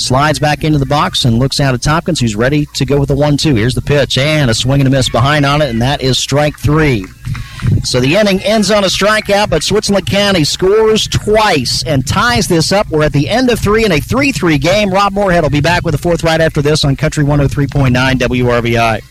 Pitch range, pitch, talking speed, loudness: 130-175 Hz, 145 Hz, 235 wpm, -11 LUFS